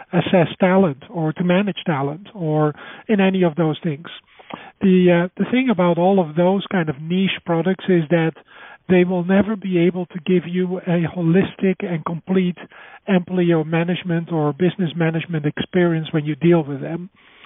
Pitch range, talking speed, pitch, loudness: 165-190 Hz, 170 wpm, 180 Hz, -19 LUFS